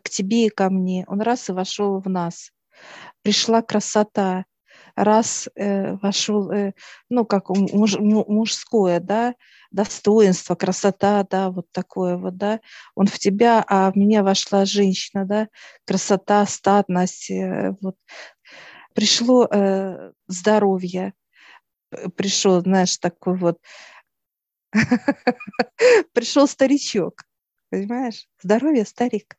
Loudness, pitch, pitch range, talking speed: -20 LUFS, 200 Hz, 190-220 Hz, 110 wpm